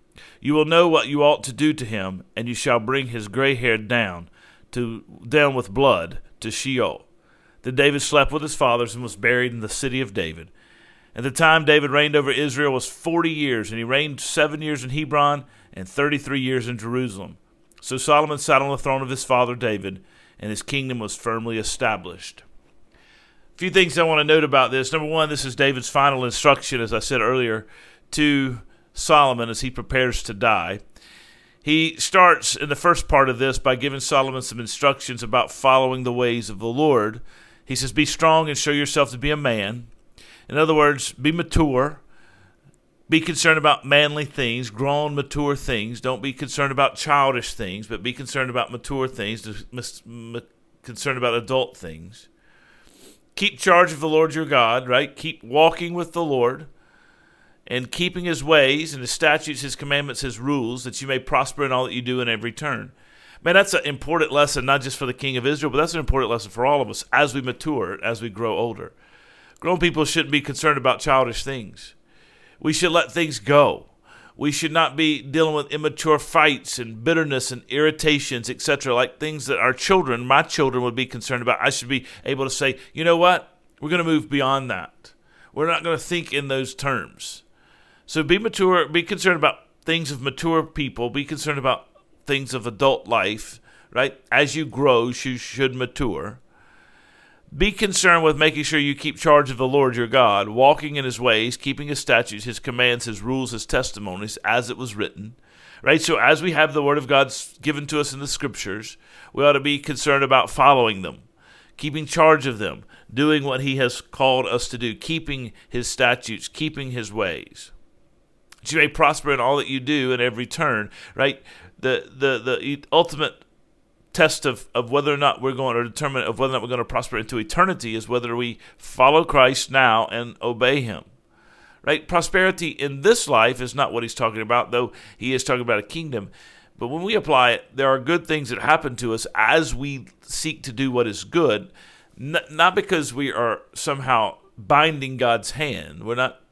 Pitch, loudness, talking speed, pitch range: 135 Hz, -21 LUFS, 195 wpm, 125-150 Hz